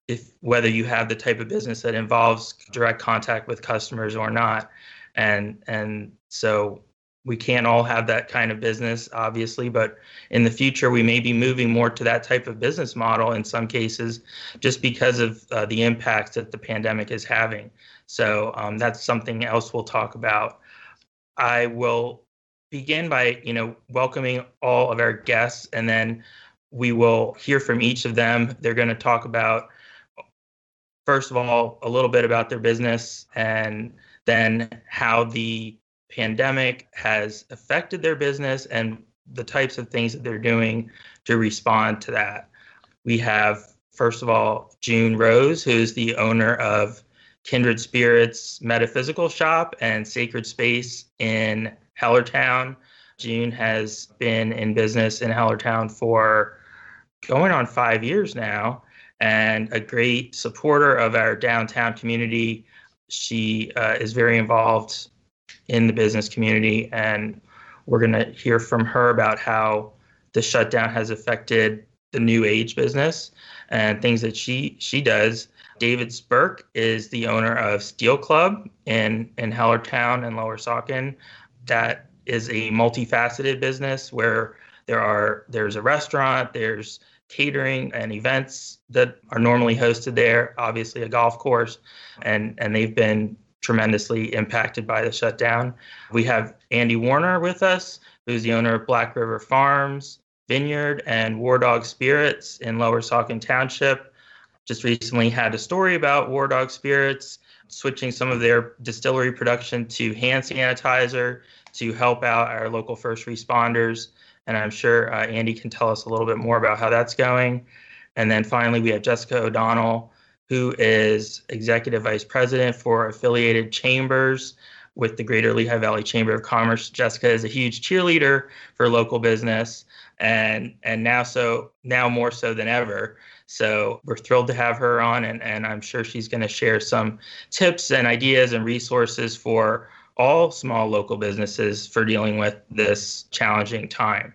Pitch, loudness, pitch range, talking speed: 115 Hz, -21 LUFS, 110-125 Hz, 155 wpm